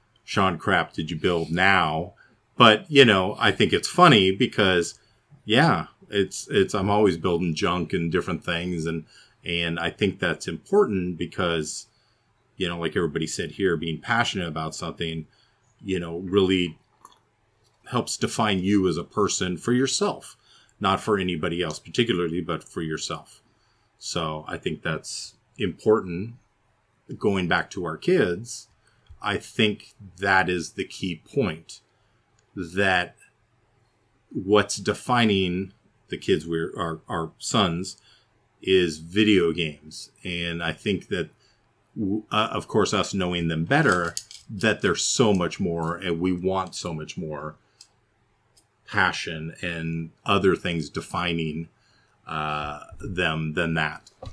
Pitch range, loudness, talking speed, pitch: 85-110 Hz, -24 LUFS, 135 wpm, 95 Hz